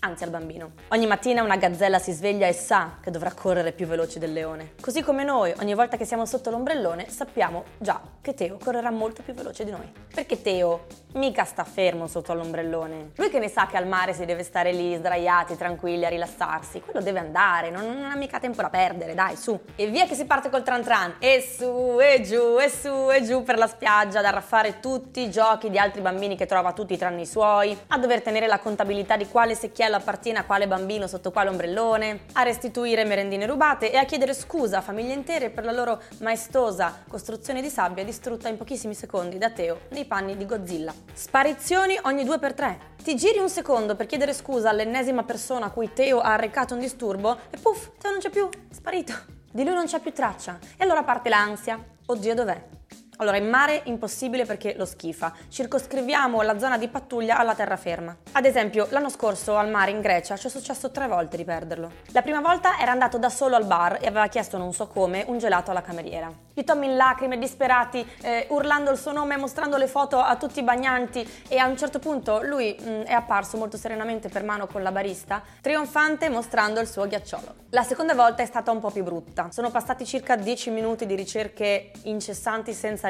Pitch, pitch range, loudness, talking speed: 225 Hz, 195-260 Hz, -24 LUFS, 210 wpm